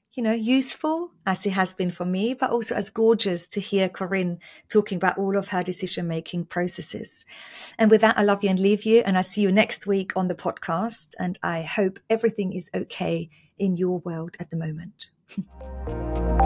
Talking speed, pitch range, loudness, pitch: 195 wpm, 175-210 Hz, -23 LUFS, 190 Hz